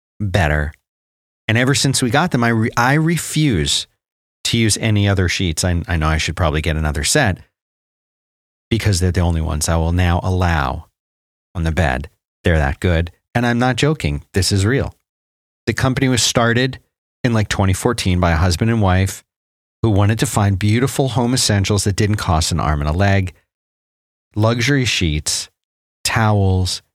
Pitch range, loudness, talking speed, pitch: 80-115 Hz, -17 LUFS, 175 wpm, 95 Hz